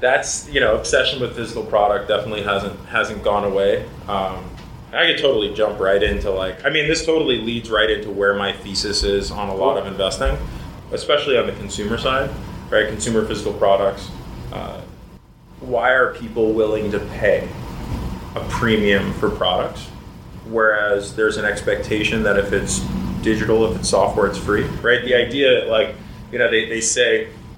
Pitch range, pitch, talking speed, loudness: 100-115 Hz, 110 Hz, 170 wpm, -19 LUFS